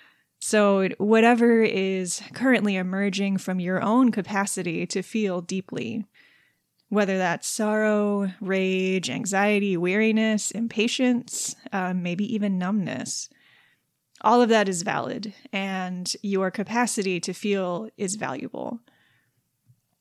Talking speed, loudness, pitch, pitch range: 105 wpm, -24 LUFS, 200 Hz, 190-220 Hz